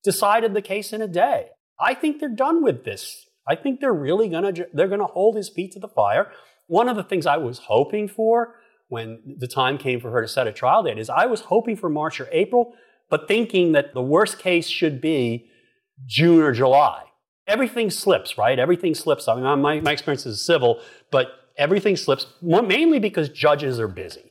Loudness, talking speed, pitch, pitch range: -21 LUFS, 210 wpm, 175 Hz, 140-220 Hz